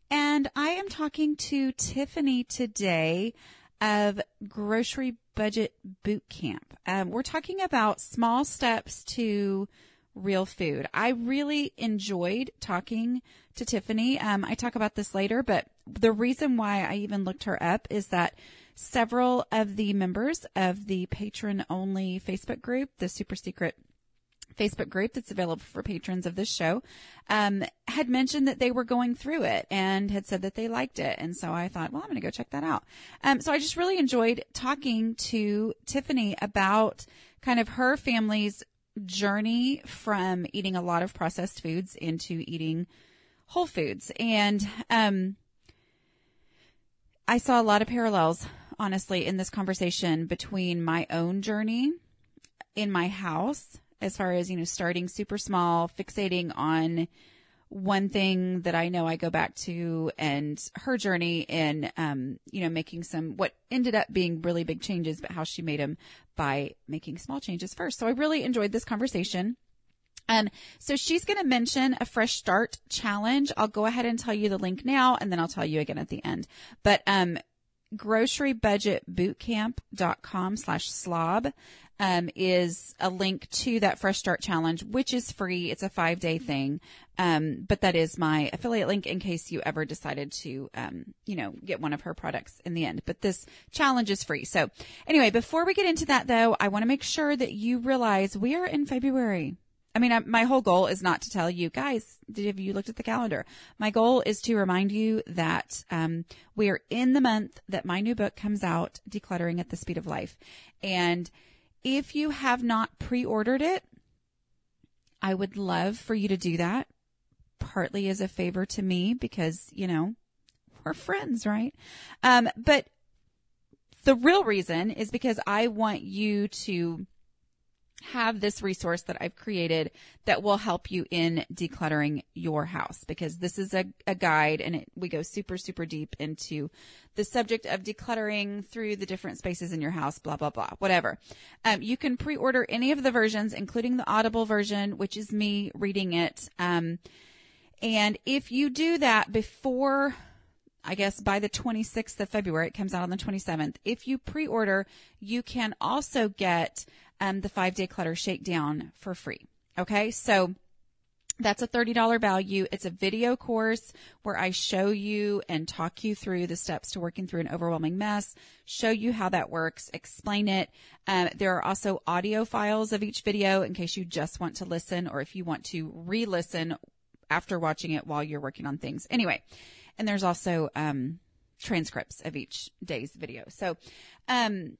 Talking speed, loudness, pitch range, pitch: 175 wpm, -29 LUFS, 175-230 Hz, 200 Hz